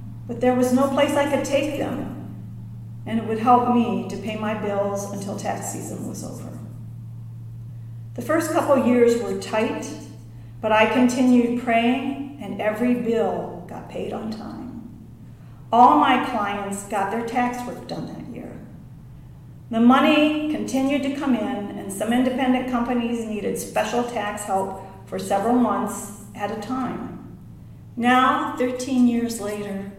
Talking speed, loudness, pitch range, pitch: 150 wpm, -22 LUFS, 200-255 Hz, 230 Hz